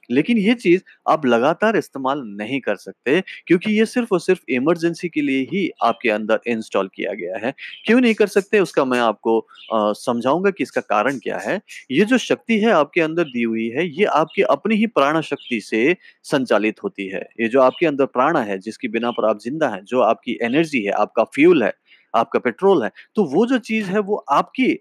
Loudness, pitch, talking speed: -19 LUFS, 170 Hz, 205 wpm